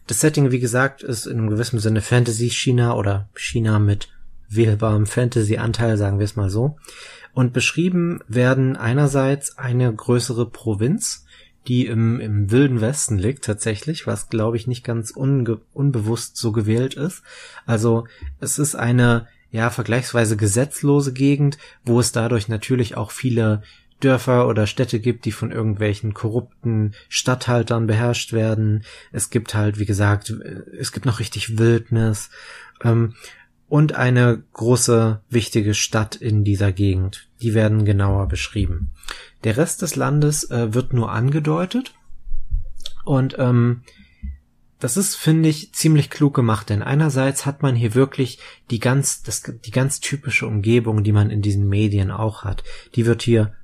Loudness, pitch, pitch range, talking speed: -20 LUFS, 115 Hz, 110-130 Hz, 150 wpm